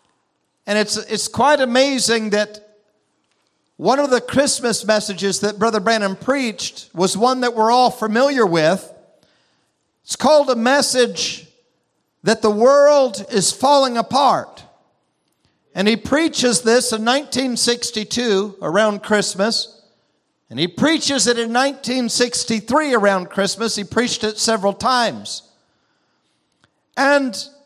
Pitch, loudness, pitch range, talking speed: 230 Hz, -17 LUFS, 210-260 Hz, 115 wpm